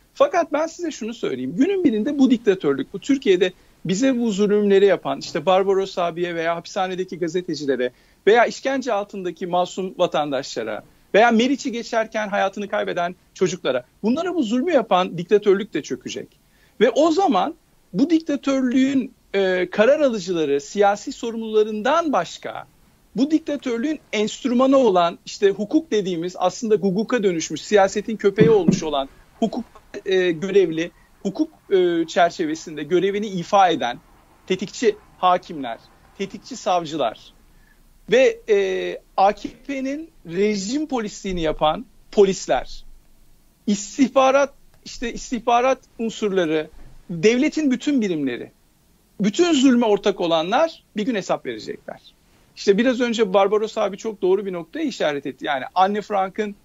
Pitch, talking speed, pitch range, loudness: 210 Hz, 120 wpm, 185-265 Hz, -21 LUFS